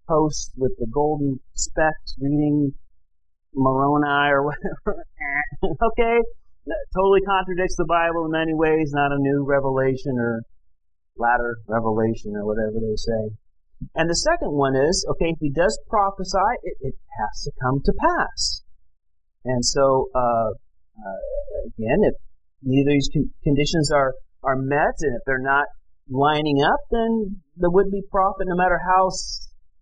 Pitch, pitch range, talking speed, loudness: 145 Hz, 120-175 Hz, 145 wpm, -22 LUFS